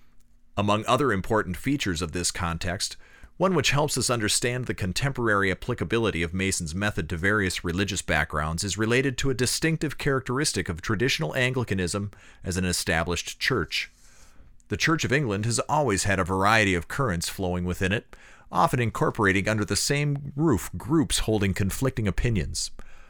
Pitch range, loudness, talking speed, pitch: 90-125 Hz, -25 LUFS, 155 wpm, 105 Hz